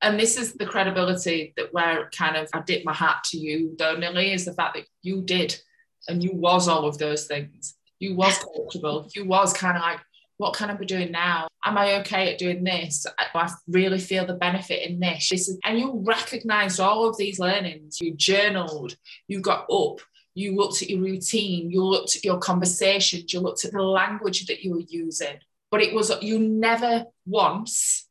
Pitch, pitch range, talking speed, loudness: 185 Hz, 170-200 Hz, 205 wpm, -24 LUFS